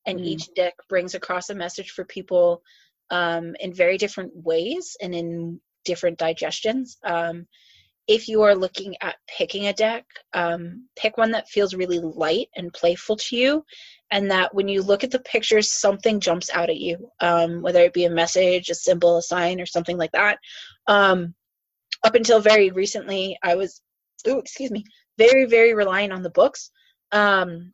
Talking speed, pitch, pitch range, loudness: 175 wpm, 185 Hz, 175-215 Hz, -21 LUFS